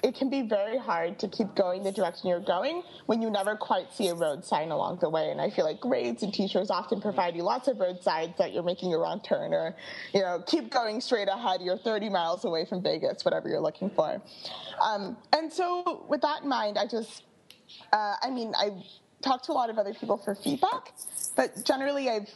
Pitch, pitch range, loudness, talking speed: 210 Hz, 190-260 Hz, -29 LUFS, 230 wpm